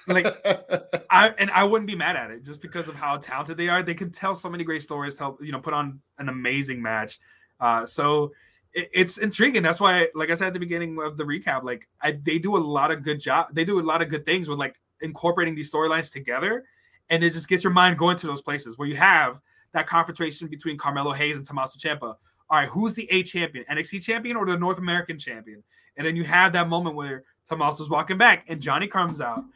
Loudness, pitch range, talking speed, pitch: -23 LUFS, 145-180 Hz, 240 wpm, 160 Hz